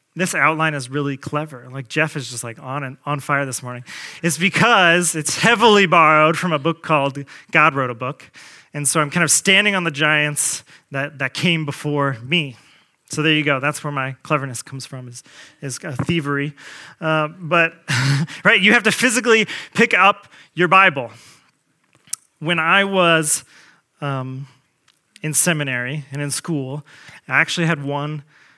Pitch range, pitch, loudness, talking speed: 140-170 Hz, 150 Hz, -17 LUFS, 170 wpm